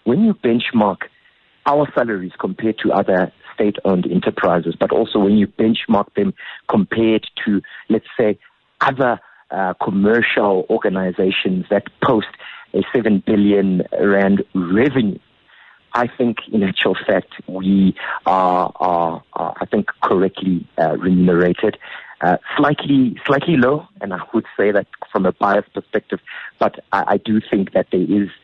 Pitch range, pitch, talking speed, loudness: 90-110 Hz, 100 Hz, 140 wpm, -18 LUFS